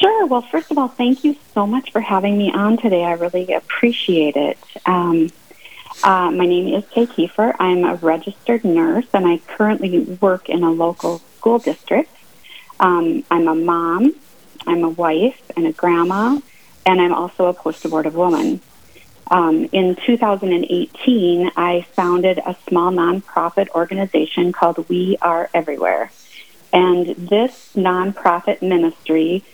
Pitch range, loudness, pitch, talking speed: 170-235 Hz, -17 LUFS, 185 Hz, 145 wpm